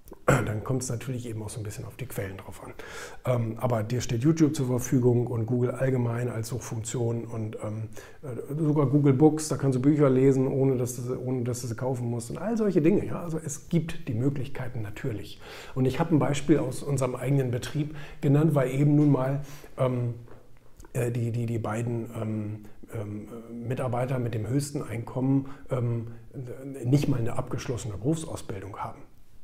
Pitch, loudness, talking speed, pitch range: 130 Hz, -28 LUFS, 165 wpm, 115-140 Hz